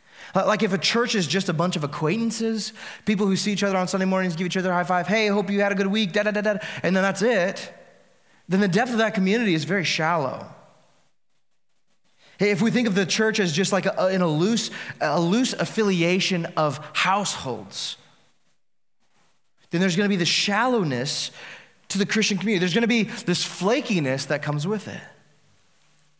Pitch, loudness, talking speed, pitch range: 195 Hz, -23 LUFS, 200 wpm, 175-215 Hz